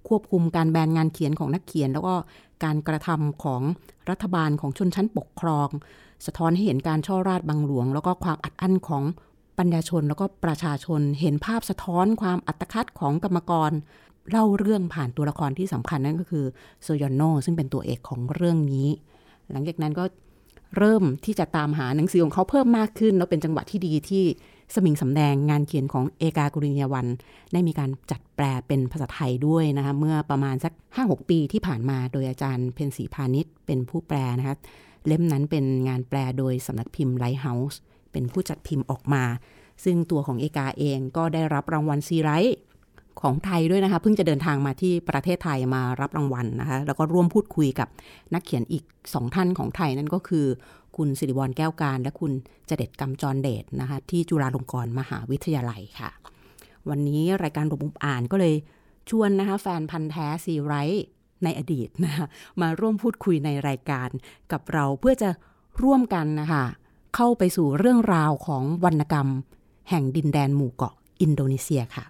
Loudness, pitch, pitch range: -25 LUFS, 155 Hz, 140-175 Hz